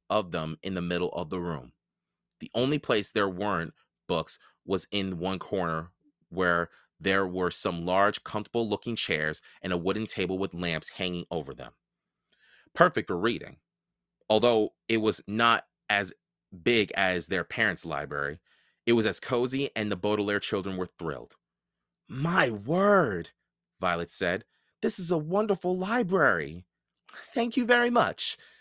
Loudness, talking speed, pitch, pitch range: -28 LUFS, 150 wpm, 100 Hz, 90-135 Hz